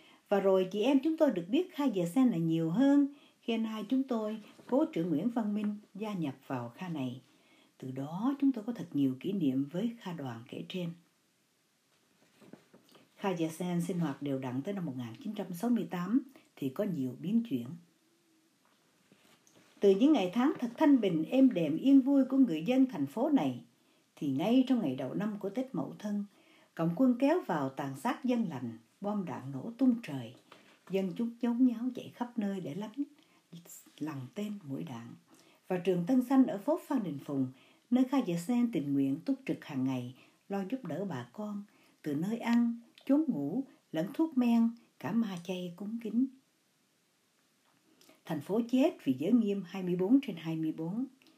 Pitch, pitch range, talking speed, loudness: 210 Hz, 165-265 Hz, 185 wpm, -32 LUFS